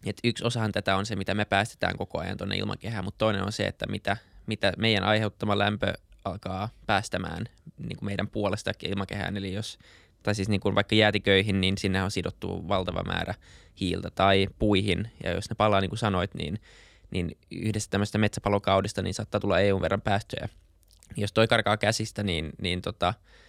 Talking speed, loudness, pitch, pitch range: 180 wpm, -28 LUFS, 100 Hz, 95-105 Hz